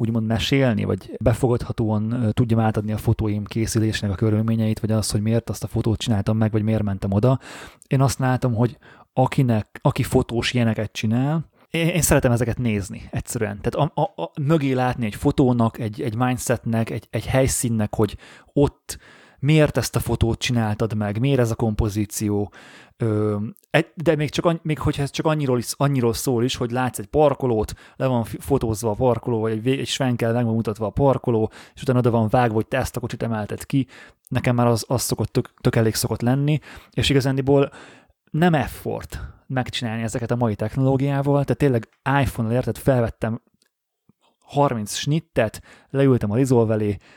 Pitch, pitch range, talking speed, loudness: 120 Hz, 110-135 Hz, 170 wpm, -22 LUFS